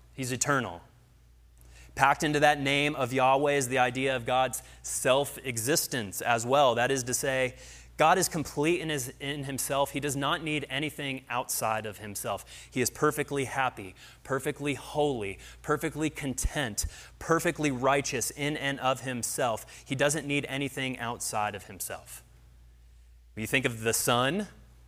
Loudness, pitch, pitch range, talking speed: -29 LUFS, 130 Hz, 115-145 Hz, 150 wpm